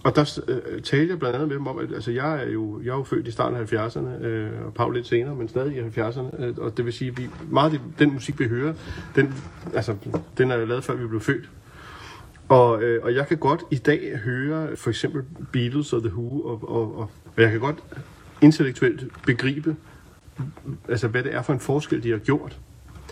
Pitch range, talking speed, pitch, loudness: 120-145 Hz, 215 wpm, 130 Hz, -24 LUFS